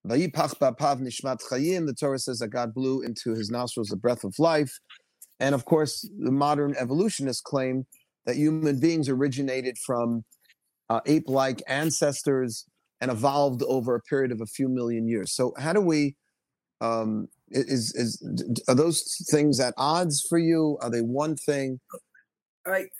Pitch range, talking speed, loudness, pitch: 120-150 Hz, 155 wpm, -26 LUFS, 135 Hz